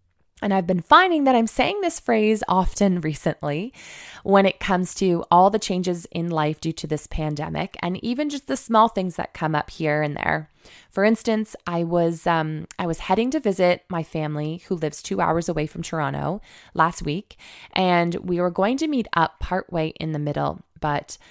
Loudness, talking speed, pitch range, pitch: -23 LUFS, 195 wpm, 160-200 Hz, 175 Hz